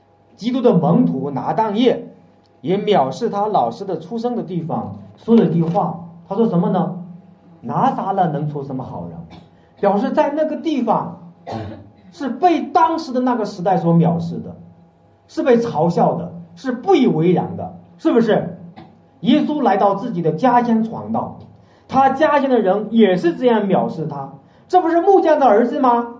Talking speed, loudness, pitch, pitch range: 240 characters per minute, -17 LUFS, 205 Hz, 170-250 Hz